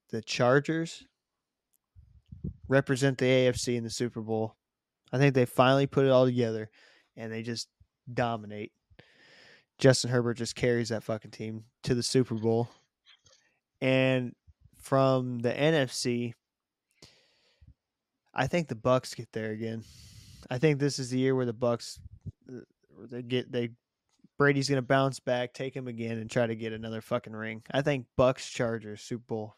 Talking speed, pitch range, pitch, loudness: 150 wpm, 115-130 Hz, 120 Hz, -29 LUFS